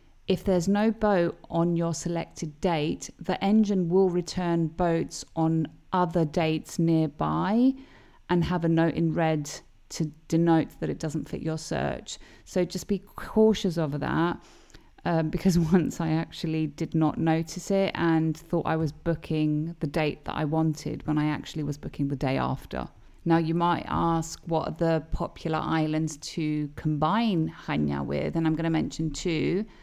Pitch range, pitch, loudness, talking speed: 155-180 Hz, 165 Hz, -27 LUFS, 165 wpm